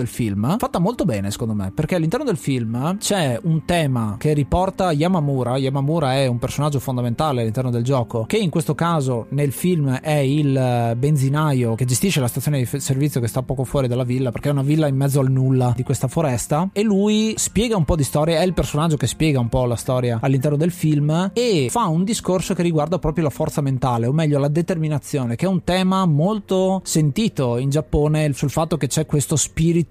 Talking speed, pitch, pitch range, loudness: 210 wpm, 150 Hz, 130-165 Hz, -20 LUFS